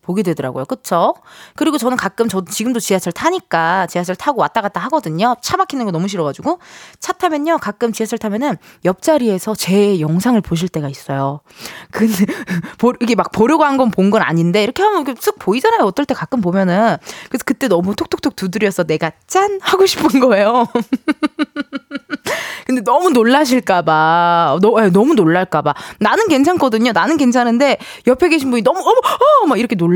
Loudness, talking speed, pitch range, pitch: -15 LUFS, 370 characters per minute, 185-290 Hz, 235 Hz